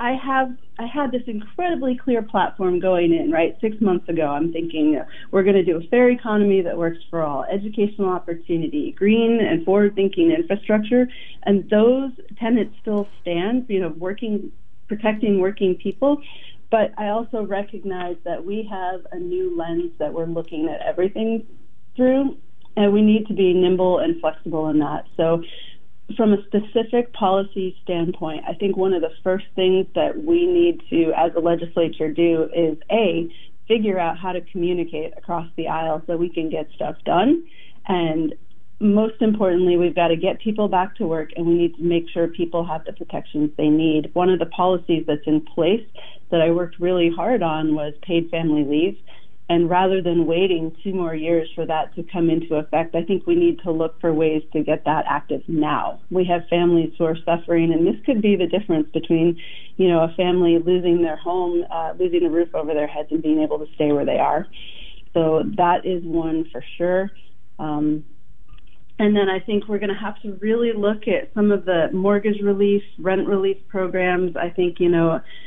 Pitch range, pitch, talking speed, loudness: 165-210 Hz, 180 Hz, 190 wpm, -21 LUFS